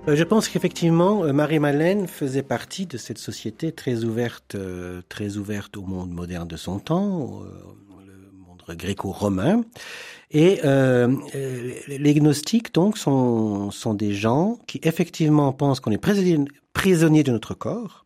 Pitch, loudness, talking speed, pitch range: 135 Hz, -22 LUFS, 135 wpm, 105-165 Hz